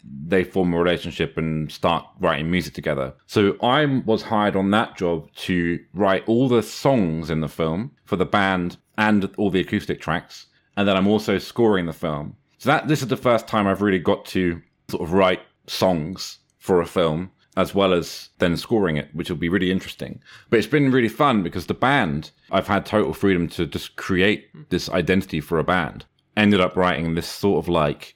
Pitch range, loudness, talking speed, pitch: 85-105 Hz, -21 LUFS, 205 wpm, 95 Hz